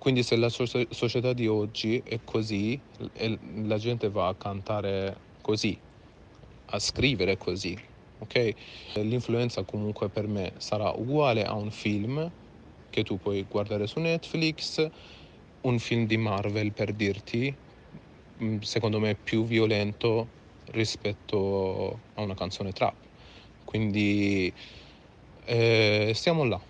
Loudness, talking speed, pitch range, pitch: -29 LUFS, 115 wpm, 105-115 Hz, 110 Hz